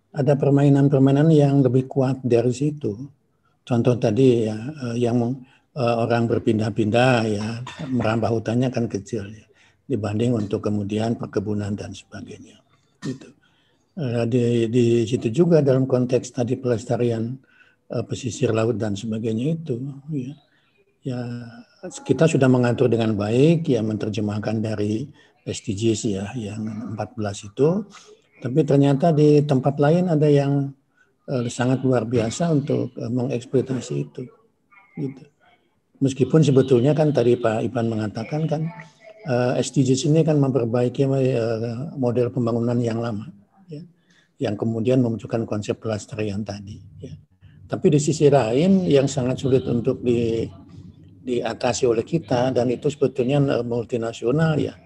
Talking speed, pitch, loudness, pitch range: 125 wpm, 125 Hz, -21 LUFS, 115-140 Hz